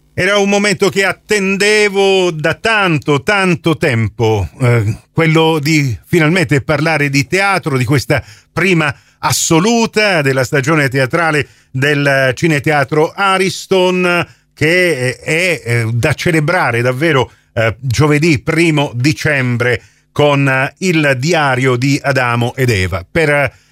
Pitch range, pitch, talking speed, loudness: 130-175 Hz, 150 Hz, 110 wpm, -13 LUFS